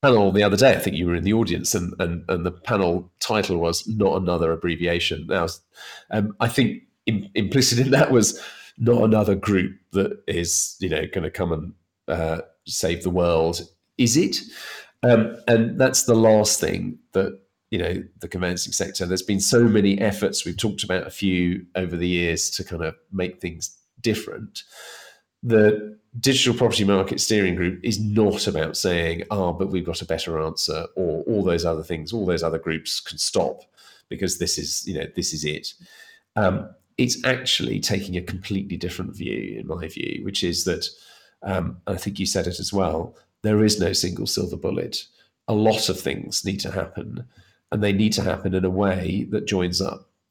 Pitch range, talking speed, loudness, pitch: 85-105 Hz, 190 wpm, -22 LUFS, 95 Hz